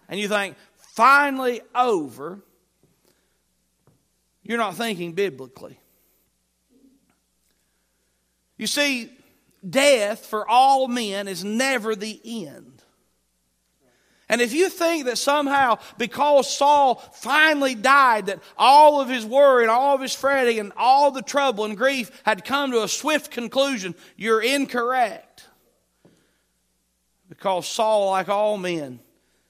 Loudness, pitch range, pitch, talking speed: -20 LUFS, 200-275 Hz, 235 Hz, 120 wpm